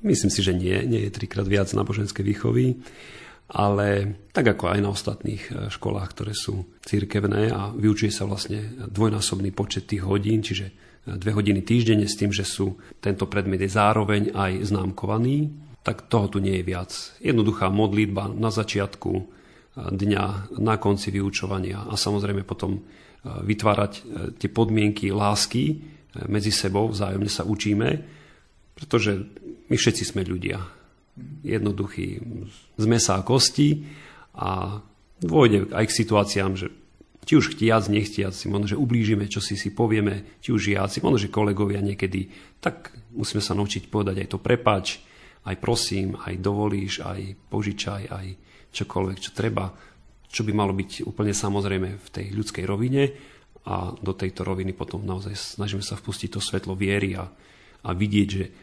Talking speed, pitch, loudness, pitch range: 150 wpm, 100 Hz, -25 LUFS, 95-110 Hz